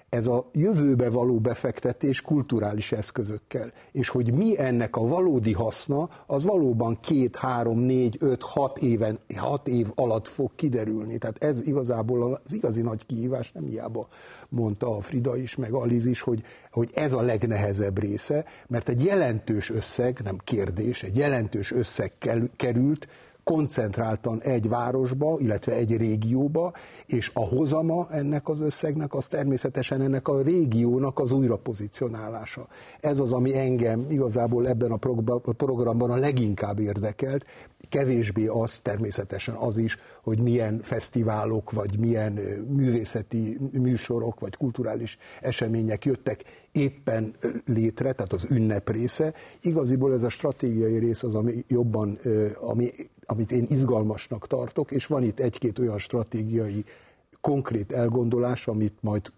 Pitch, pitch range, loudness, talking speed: 120 Hz, 110-135 Hz, -26 LUFS, 135 wpm